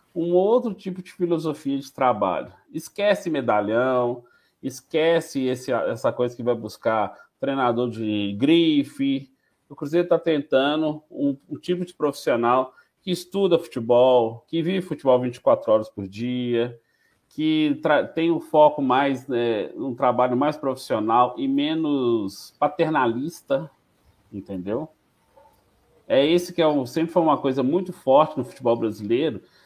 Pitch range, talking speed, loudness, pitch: 120-170 Hz, 135 wpm, -23 LUFS, 140 Hz